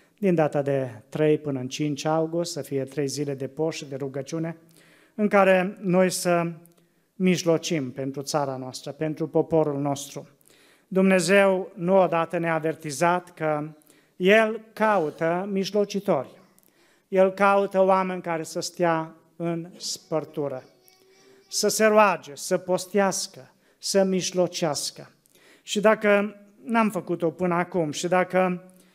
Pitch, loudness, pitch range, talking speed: 170 Hz, -24 LUFS, 155-190 Hz, 120 wpm